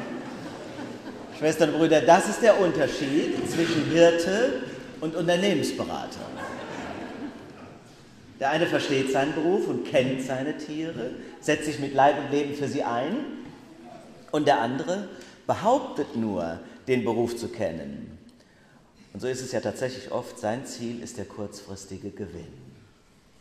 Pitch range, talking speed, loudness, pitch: 115-155 Hz, 130 wpm, -26 LUFS, 135 Hz